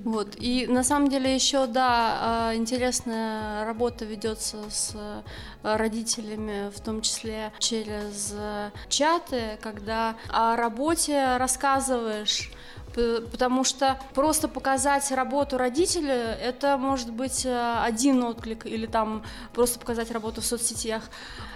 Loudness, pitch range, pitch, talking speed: -26 LUFS, 220-260 Hz, 235 Hz, 110 wpm